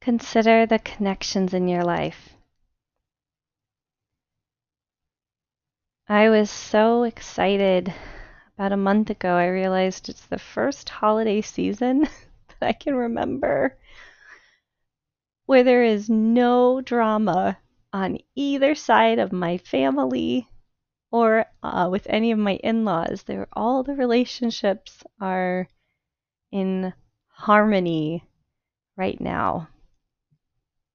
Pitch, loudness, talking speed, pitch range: 210 Hz, -22 LUFS, 100 wpm, 185-230 Hz